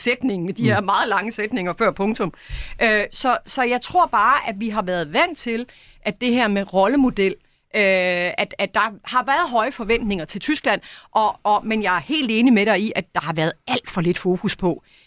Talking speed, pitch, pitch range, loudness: 205 wpm, 210 Hz, 190-240 Hz, -20 LUFS